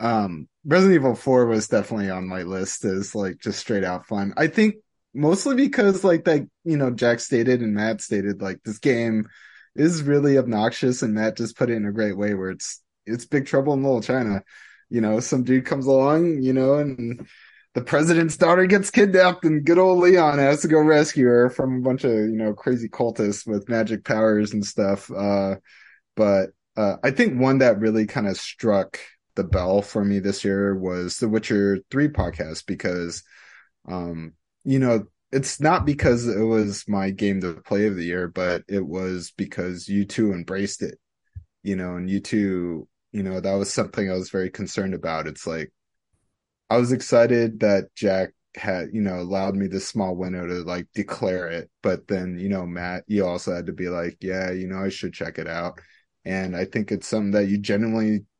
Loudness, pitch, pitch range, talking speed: -22 LUFS, 105 Hz, 95-130 Hz, 200 wpm